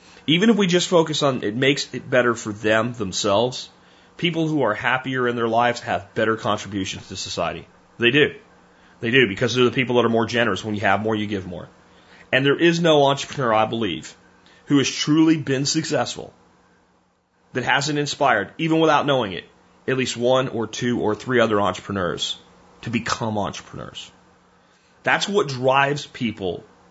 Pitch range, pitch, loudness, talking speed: 95-135 Hz, 115 Hz, -21 LUFS, 175 wpm